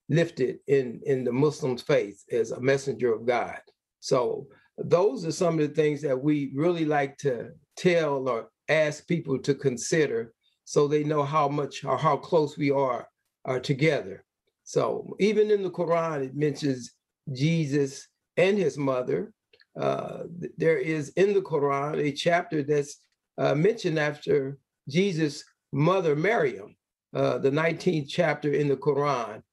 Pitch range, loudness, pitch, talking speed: 140-175 Hz, -26 LUFS, 150 Hz, 150 wpm